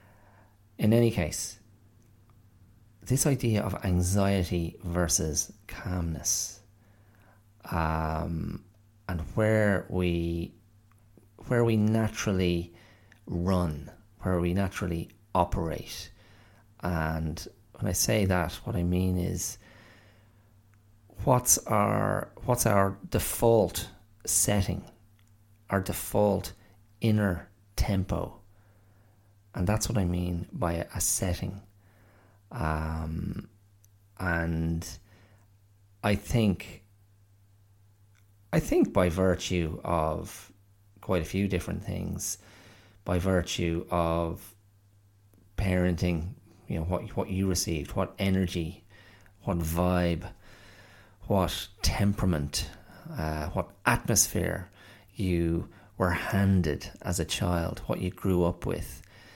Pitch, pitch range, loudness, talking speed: 100 Hz, 90-105 Hz, -29 LUFS, 95 wpm